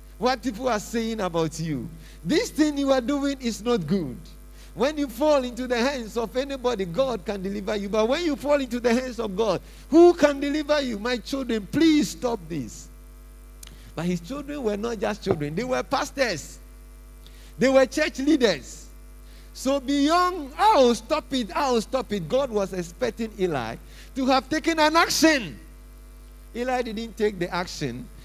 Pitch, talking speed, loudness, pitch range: 240 Hz, 170 wpm, -24 LUFS, 195-280 Hz